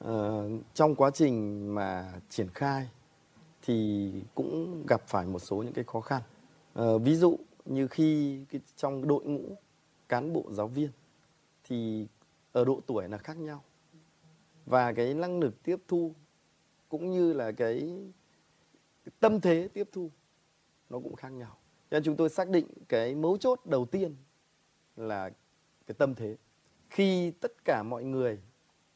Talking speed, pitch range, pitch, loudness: 160 wpm, 115-160 Hz, 140 Hz, -31 LUFS